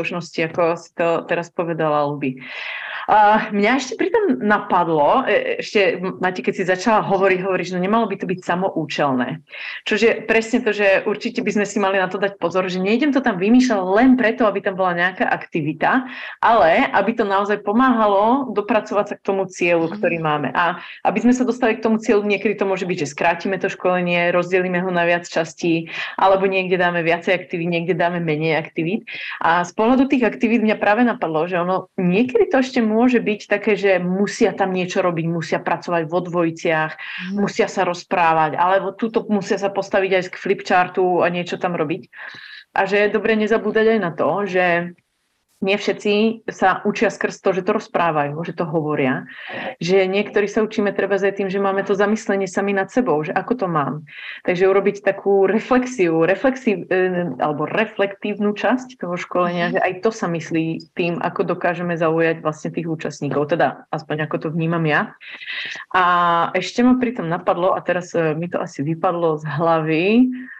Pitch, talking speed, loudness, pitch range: 190 Hz, 180 wpm, -19 LUFS, 175-210 Hz